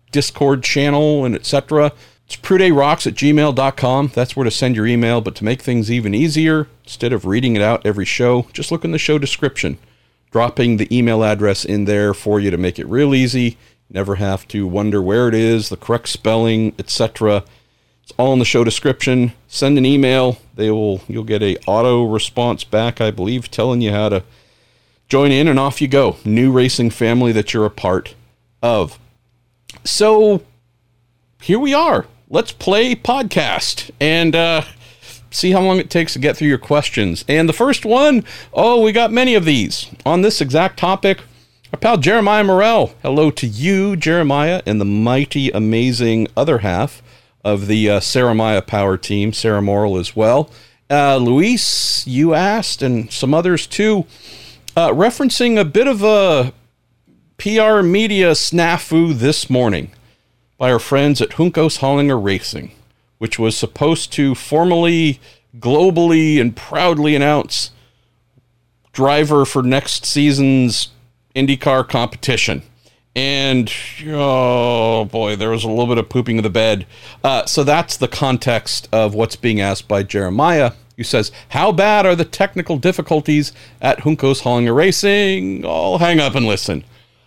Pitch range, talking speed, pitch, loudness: 115-155 Hz, 160 wpm, 125 Hz, -15 LUFS